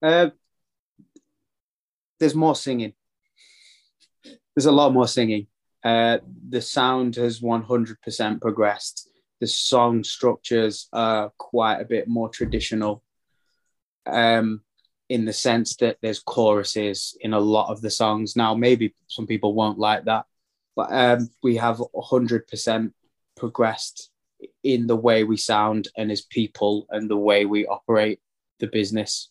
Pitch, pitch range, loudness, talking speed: 115 Hz, 105-125 Hz, -22 LUFS, 135 wpm